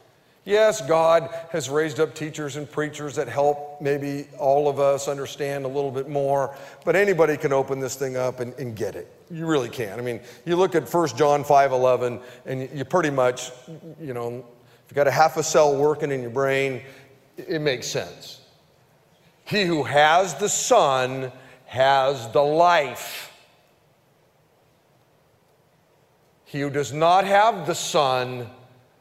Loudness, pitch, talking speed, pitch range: -22 LUFS, 145 Hz, 160 wpm, 130-160 Hz